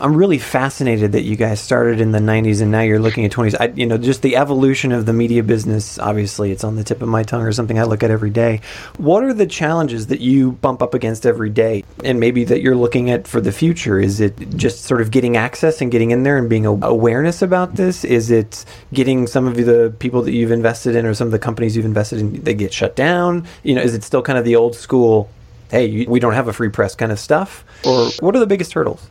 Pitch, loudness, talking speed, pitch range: 115 Hz, -16 LUFS, 260 wpm, 110-130 Hz